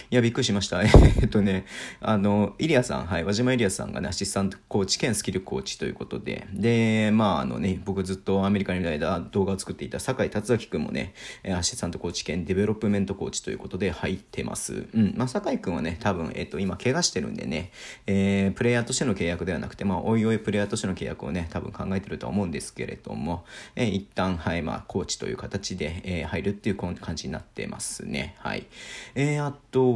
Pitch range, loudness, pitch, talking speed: 95-110 Hz, -26 LUFS, 100 Hz, 475 characters per minute